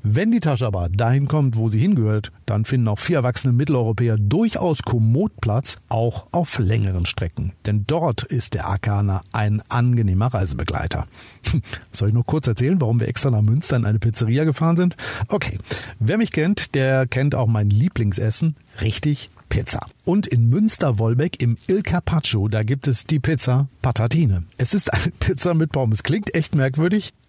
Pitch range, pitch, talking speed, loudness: 110-145 Hz, 120 Hz, 170 wpm, -20 LUFS